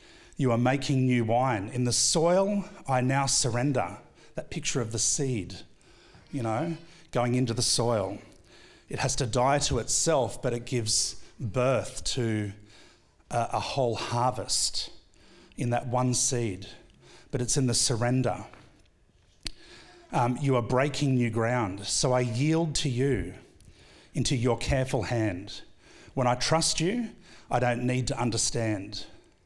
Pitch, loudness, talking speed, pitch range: 125 Hz, -27 LUFS, 145 wpm, 115-140 Hz